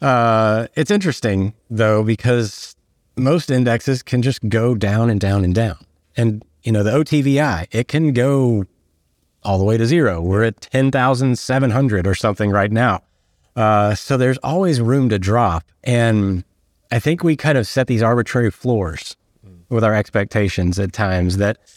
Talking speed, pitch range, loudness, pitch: 160 wpm, 100-125 Hz, -17 LUFS, 115 Hz